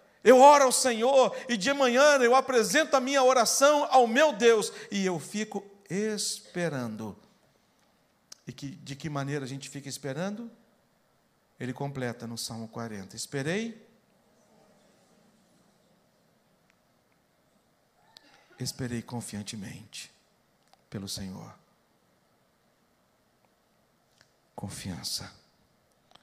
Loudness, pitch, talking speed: -26 LUFS, 205 Hz, 90 wpm